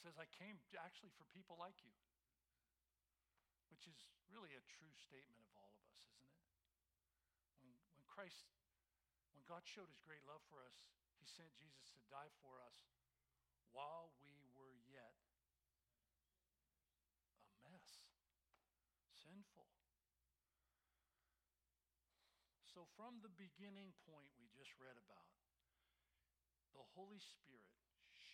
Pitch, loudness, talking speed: 80 Hz, -63 LUFS, 120 wpm